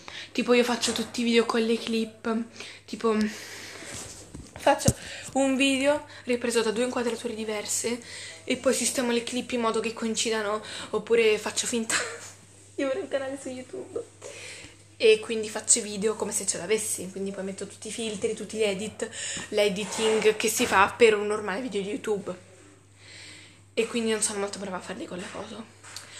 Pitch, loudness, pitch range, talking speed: 225 Hz, -26 LUFS, 210-240 Hz, 170 wpm